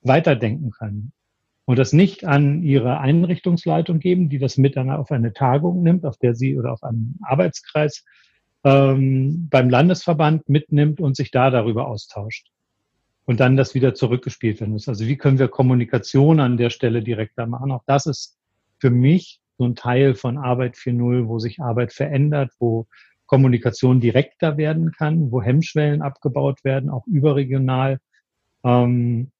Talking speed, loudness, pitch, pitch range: 155 wpm, -19 LUFS, 135 Hz, 120-145 Hz